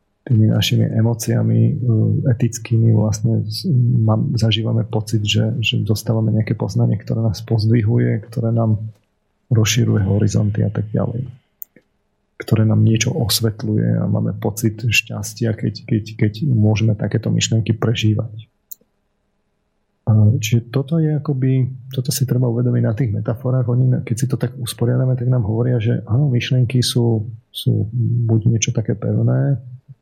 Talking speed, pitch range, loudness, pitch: 130 wpm, 110-125 Hz, -18 LUFS, 115 Hz